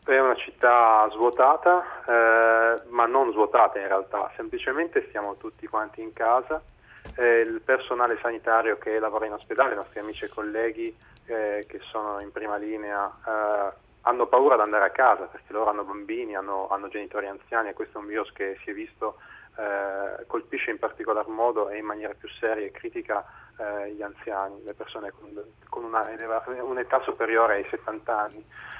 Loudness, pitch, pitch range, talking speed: -25 LUFS, 115 Hz, 105-125 Hz, 175 wpm